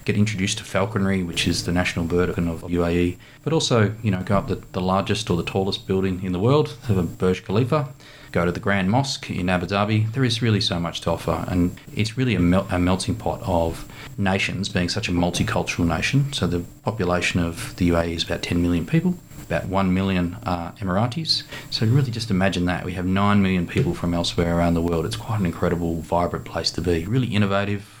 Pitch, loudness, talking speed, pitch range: 95 Hz, -22 LUFS, 215 wpm, 90-110 Hz